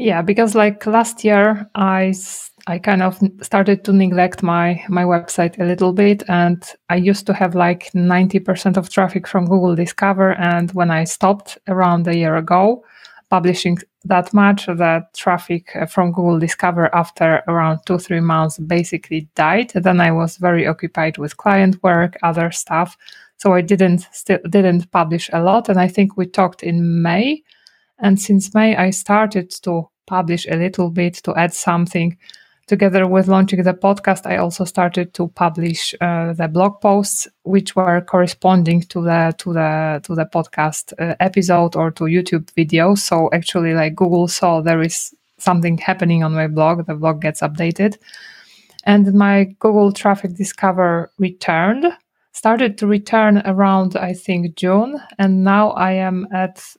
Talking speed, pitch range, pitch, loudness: 165 wpm, 170-195 Hz, 180 Hz, -16 LUFS